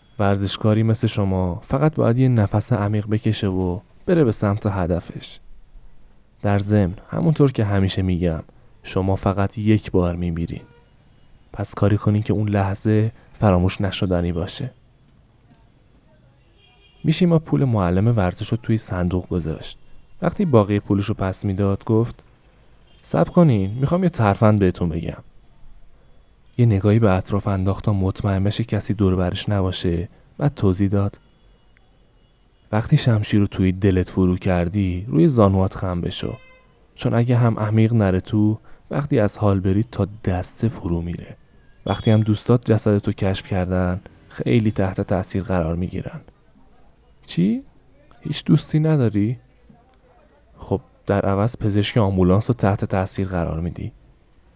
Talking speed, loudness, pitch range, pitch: 135 wpm, -20 LUFS, 95-115 Hz, 105 Hz